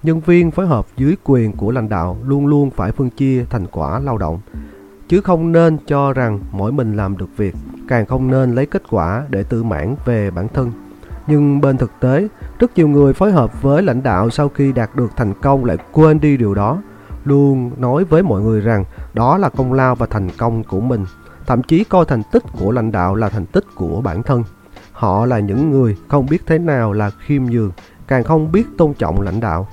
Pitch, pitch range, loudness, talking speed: 125 Hz, 105-145 Hz, -15 LUFS, 220 wpm